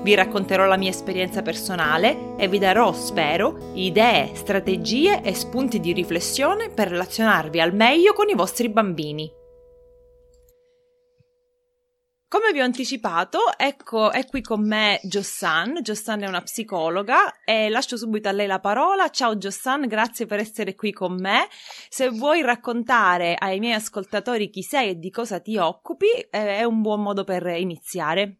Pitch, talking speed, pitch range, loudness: 220 Hz, 150 wpm, 190-270 Hz, -21 LUFS